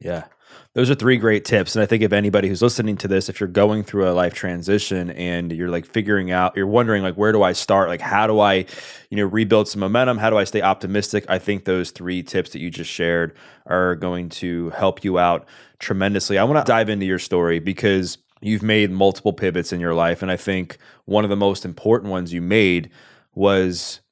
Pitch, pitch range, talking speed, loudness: 95 Hz, 90-105 Hz, 225 wpm, -20 LUFS